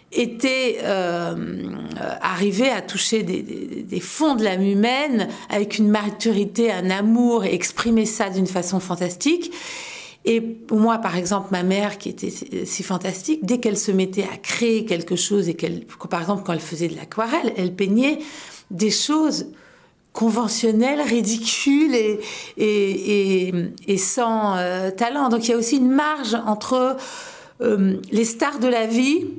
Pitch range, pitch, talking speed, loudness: 190-240 Hz, 220 Hz, 160 wpm, -21 LUFS